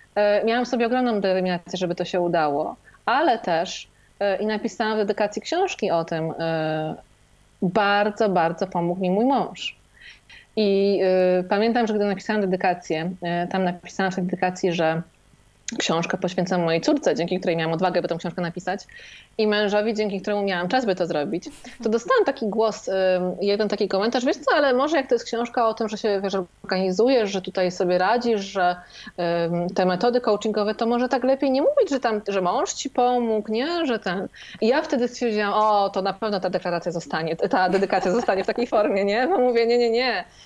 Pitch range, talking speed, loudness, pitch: 180-230 Hz, 185 wpm, -23 LUFS, 200 Hz